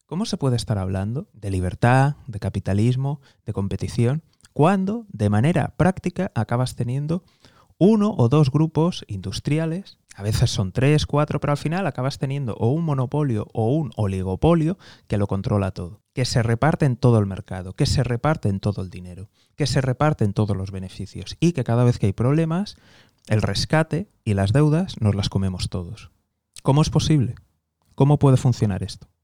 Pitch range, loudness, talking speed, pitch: 100-150 Hz, -22 LUFS, 175 wpm, 120 Hz